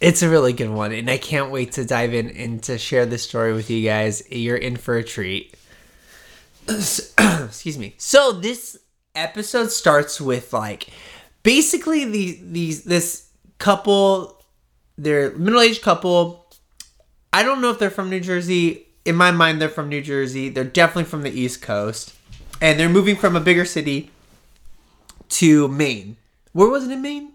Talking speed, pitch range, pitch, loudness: 170 wpm, 125-195 Hz, 155 Hz, -19 LUFS